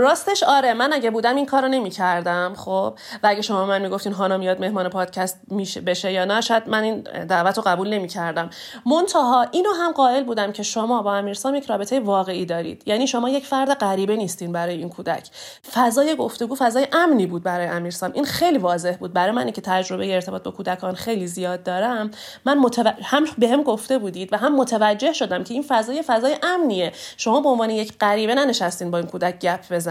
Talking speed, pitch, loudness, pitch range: 195 wpm, 215 Hz, -21 LUFS, 185-265 Hz